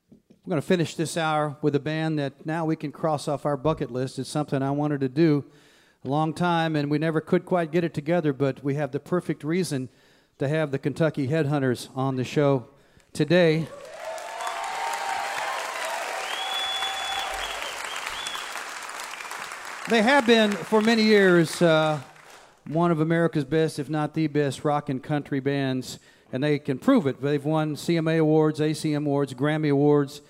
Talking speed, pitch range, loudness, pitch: 160 wpm, 140-165 Hz, -25 LUFS, 150 Hz